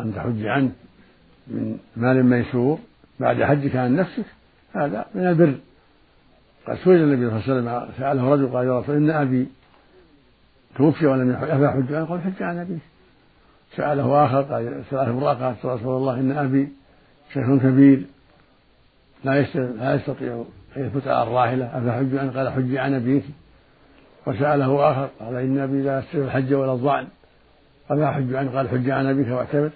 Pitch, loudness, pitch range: 135 Hz, -21 LUFS, 125-145 Hz